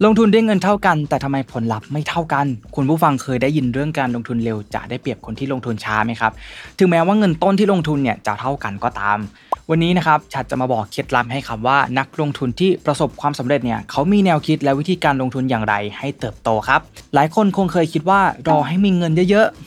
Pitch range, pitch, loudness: 120-170 Hz, 140 Hz, -18 LUFS